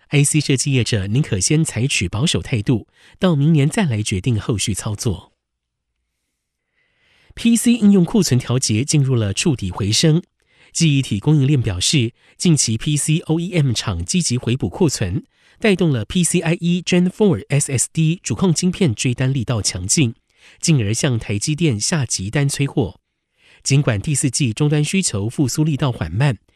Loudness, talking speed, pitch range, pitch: -18 LUFS, 260 characters per minute, 110-160 Hz, 140 Hz